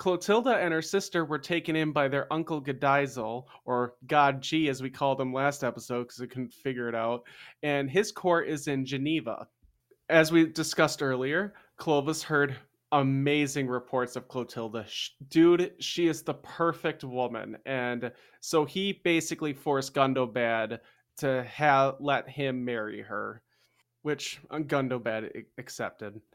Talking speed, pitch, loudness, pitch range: 145 wpm, 140 Hz, -29 LUFS, 125-160 Hz